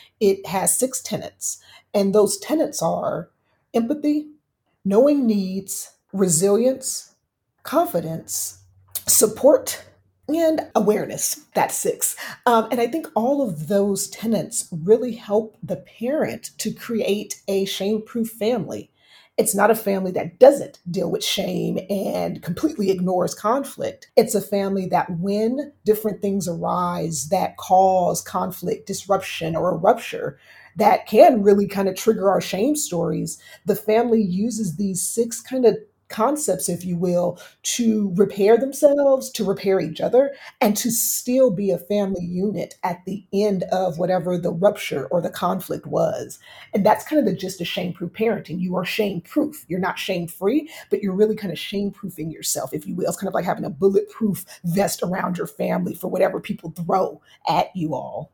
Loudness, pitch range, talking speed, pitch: -21 LUFS, 185-230 Hz, 160 wpm, 200 Hz